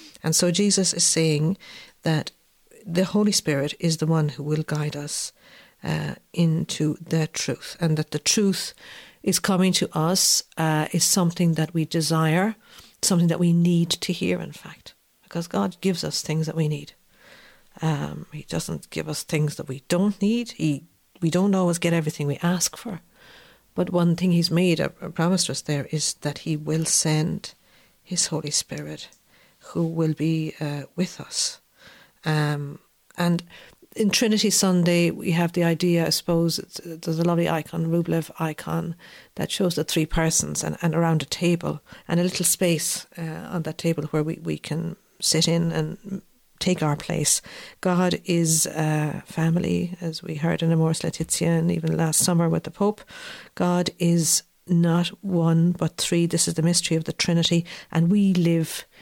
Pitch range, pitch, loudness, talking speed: 160-180 Hz, 170 Hz, -23 LUFS, 175 wpm